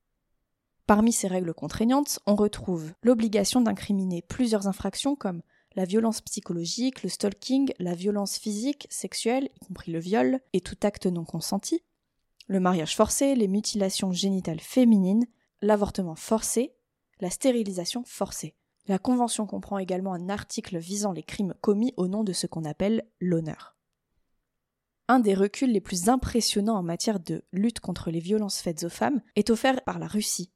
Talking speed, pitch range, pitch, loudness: 155 wpm, 185-230 Hz, 205 Hz, -27 LUFS